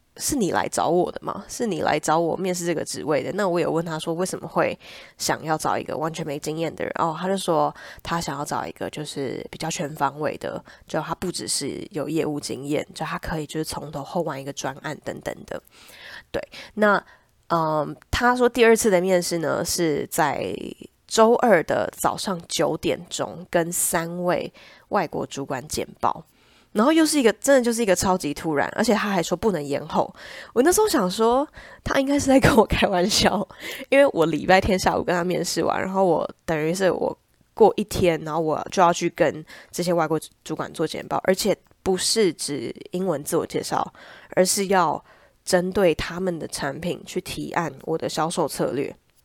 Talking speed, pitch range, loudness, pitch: 275 characters per minute, 155-190 Hz, -23 LUFS, 175 Hz